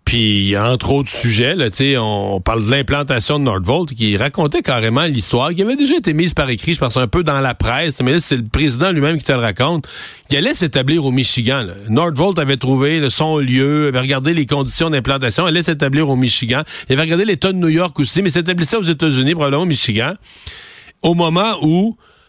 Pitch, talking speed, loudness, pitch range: 145 Hz, 210 wpm, -15 LUFS, 125-165 Hz